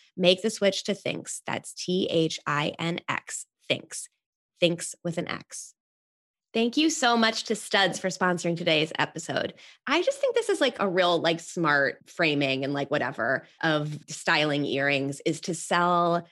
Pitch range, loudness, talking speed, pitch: 155-200 Hz, -26 LUFS, 170 wpm, 175 Hz